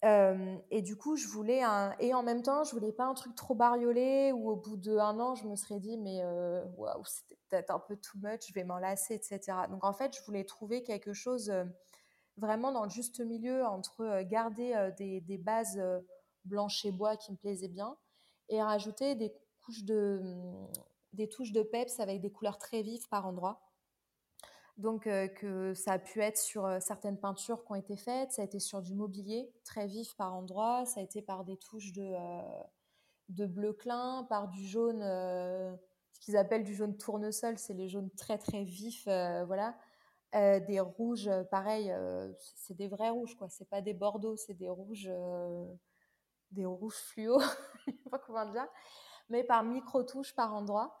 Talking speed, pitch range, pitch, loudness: 200 wpm, 195-230 Hz, 210 Hz, -36 LUFS